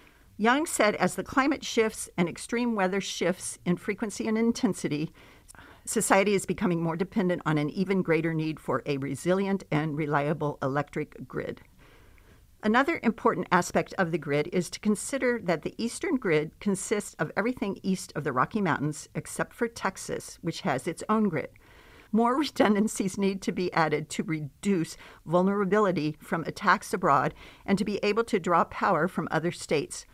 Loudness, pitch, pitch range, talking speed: -28 LUFS, 190 Hz, 160-215 Hz, 165 wpm